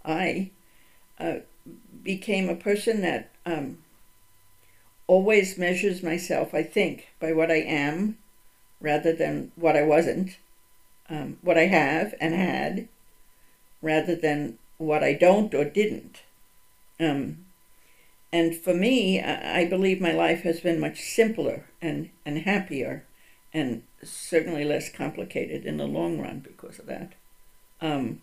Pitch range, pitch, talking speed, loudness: 150-185 Hz, 165 Hz, 130 wpm, -26 LUFS